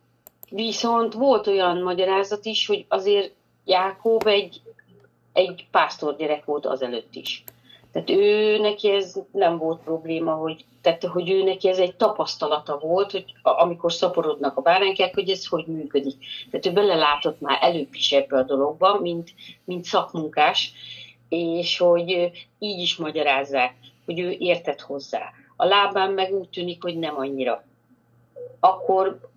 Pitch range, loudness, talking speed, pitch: 155-195 Hz, -22 LUFS, 135 wpm, 180 Hz